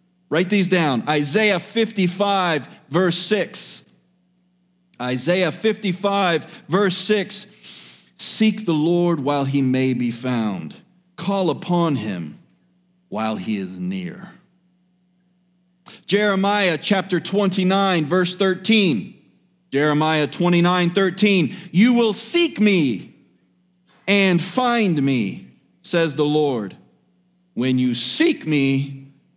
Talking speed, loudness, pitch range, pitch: 100 wpm, -19 LUFS, 155-195 Hz, 180 Hz